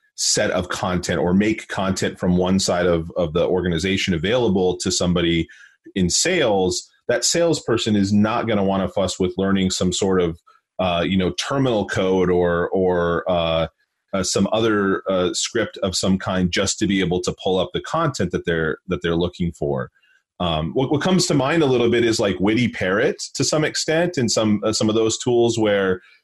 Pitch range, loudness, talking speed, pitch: 90-115 Hz, -20 LUFS, 200 wpm, 95 Hz